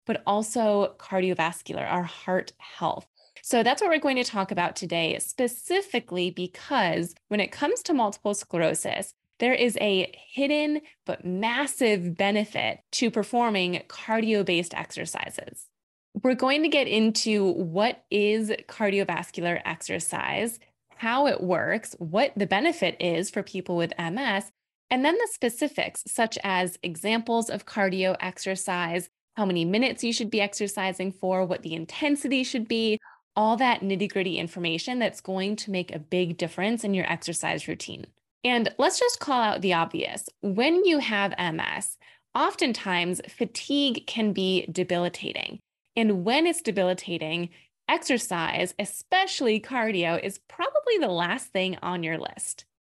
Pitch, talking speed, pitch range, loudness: 205 Hz, 140 wpm, 180-245 Hz, -26 LUFS